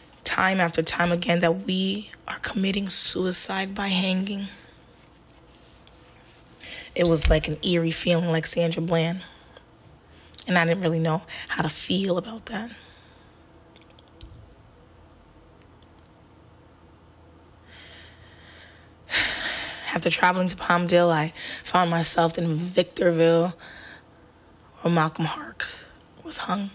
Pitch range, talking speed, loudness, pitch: 155-180 Hz, 100 wpm, -22 LUFS, 170 Hz